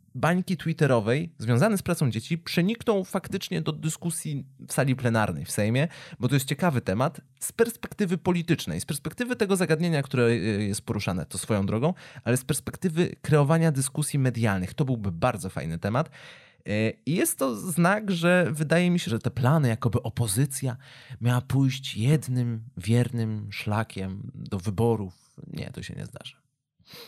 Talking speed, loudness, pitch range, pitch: 155 wpm, -26 LUFS, 115-165 Hz, 135 Hz